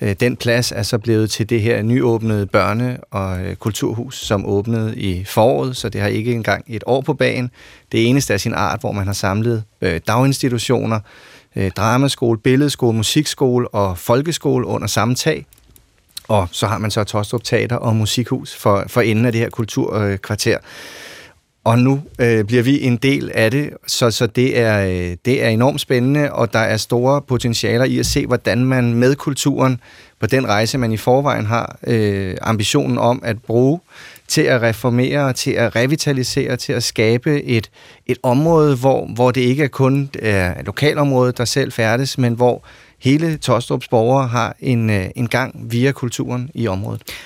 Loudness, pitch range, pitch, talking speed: -17 LUFS, 110-130 Hz, 120 Hz, 175 wpm